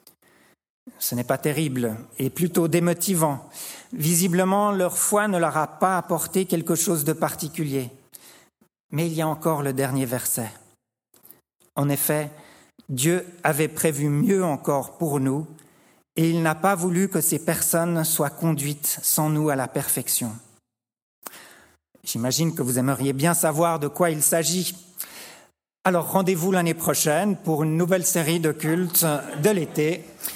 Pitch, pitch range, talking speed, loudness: 160 Hz, 145-175 Hz, 145 wpm, -23 LUFS